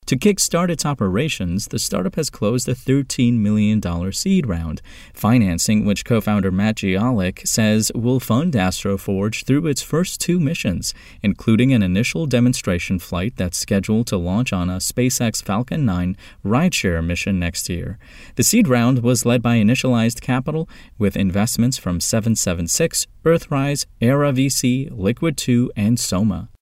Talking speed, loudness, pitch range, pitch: 145 wpm, -19 LUFS, 95-130 Hz, 115 Hz